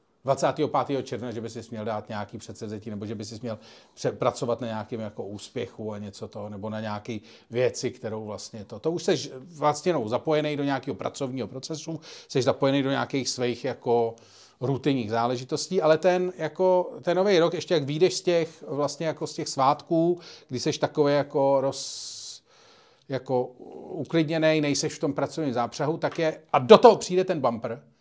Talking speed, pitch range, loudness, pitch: 180 wpm, 115-160 Hz, -26 LUFS, 135 Hz